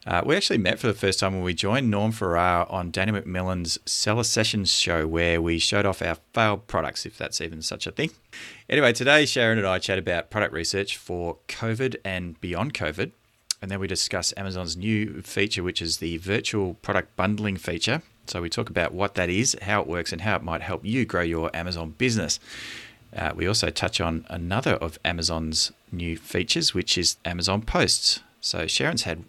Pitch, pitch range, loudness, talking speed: 95 Hz, 85-105 Hz, -25 LUFS, 200 wpm